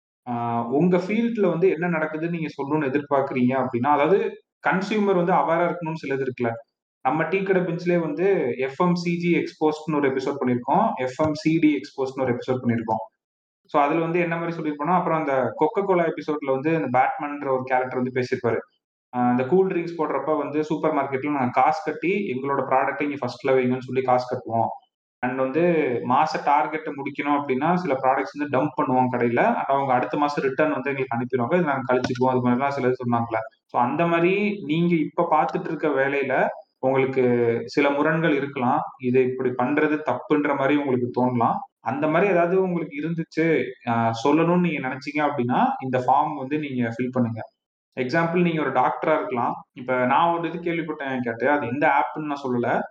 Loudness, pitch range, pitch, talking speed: -23 LUFS, 130-160 Hz, 145 Hz, 165 wpm